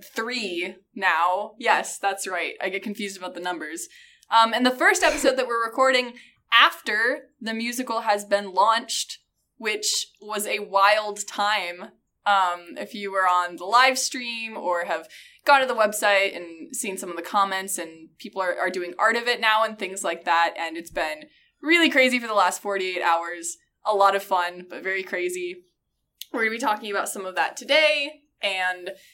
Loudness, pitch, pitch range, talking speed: -23 LUFS, 210 Hz, 185-255 Hz, 185 wpm